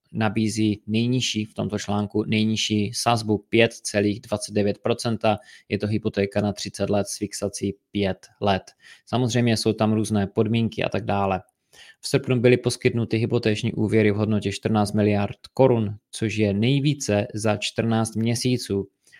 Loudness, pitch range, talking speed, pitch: -23 LUFS, 105-115 Hz, 135 wpm, 110 Hz